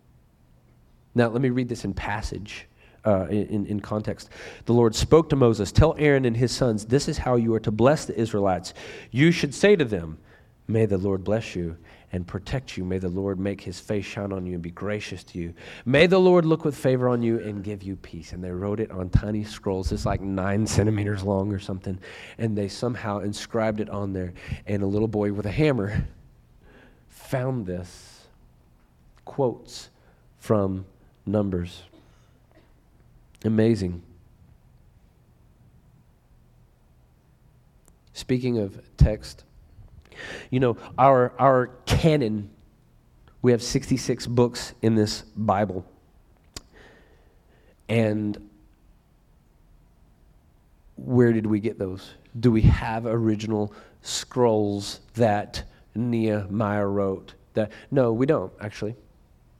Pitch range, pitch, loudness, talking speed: 95-115 Hz, 105 Hz, -24 LUFS, 140 wpm